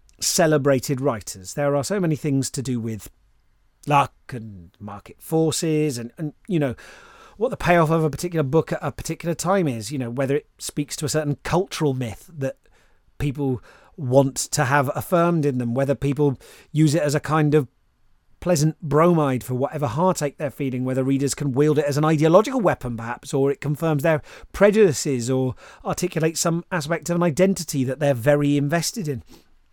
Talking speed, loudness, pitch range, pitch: 180 wpm, -22 LUFS, 135-160 Hz, 145 Hz